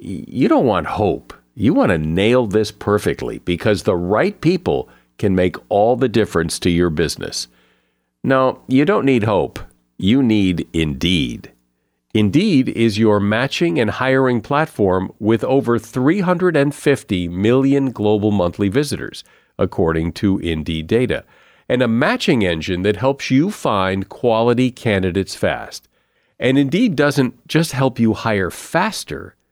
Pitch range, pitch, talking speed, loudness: 90-130 Hz, 110 Hz, 135 wpm, -17 LUFS